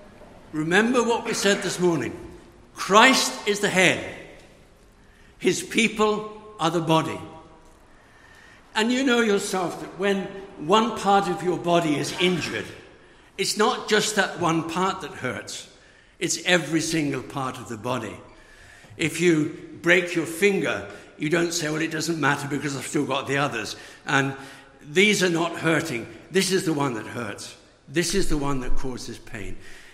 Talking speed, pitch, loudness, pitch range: 160 wpm, 170 Hz, -23 LUFS, 145-195 Hz